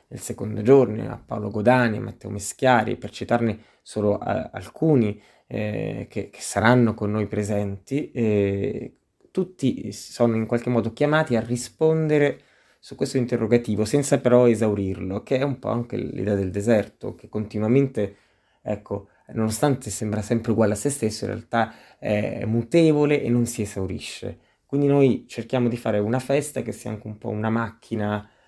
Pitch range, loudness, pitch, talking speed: 105-130 Hz, -23 LUFS, 115 Hz, 160 wpm